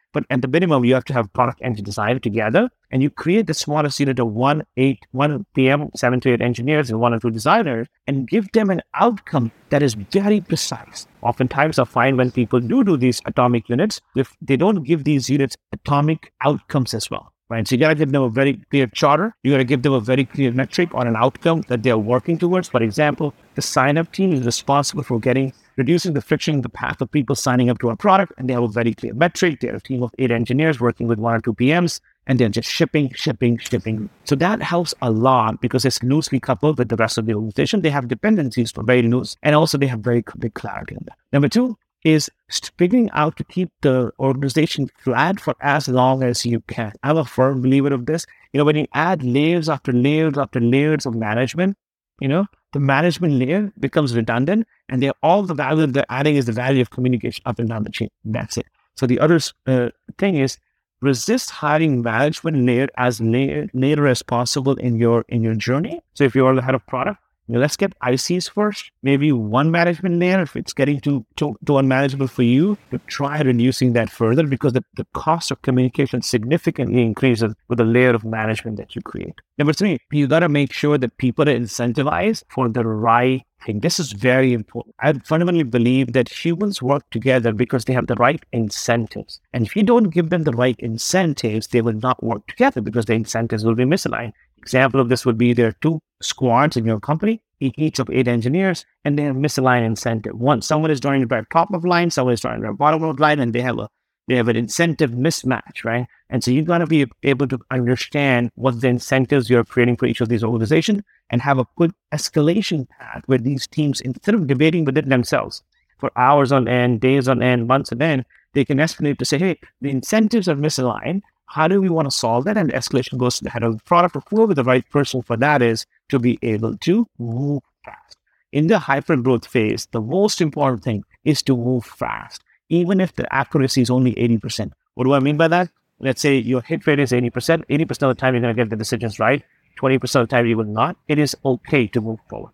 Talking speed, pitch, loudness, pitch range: 225 wpm, 135 Hz, -19 LUFS, 120-155 Hz